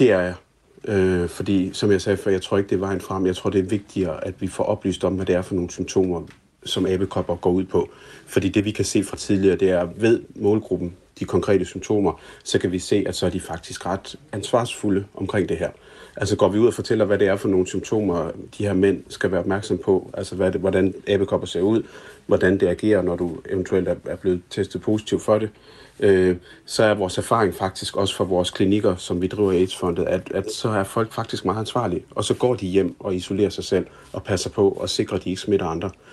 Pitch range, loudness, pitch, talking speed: 90-105 Hz, -22 LUFS, 95 Hz, 240 wpm